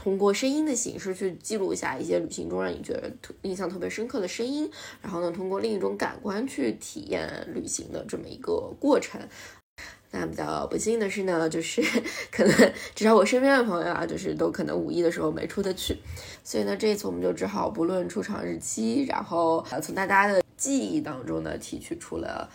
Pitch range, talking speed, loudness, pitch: 170-250 Hz, 315 characters per minute, -27 LUFS, 195 Hz